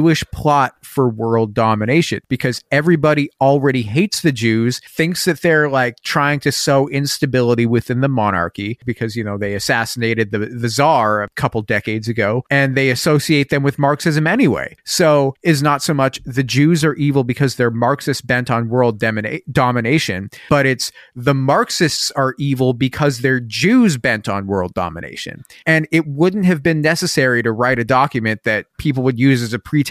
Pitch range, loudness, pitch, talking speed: 120-150 Hz, -16 LUFS, 135 Hz, 175 wpm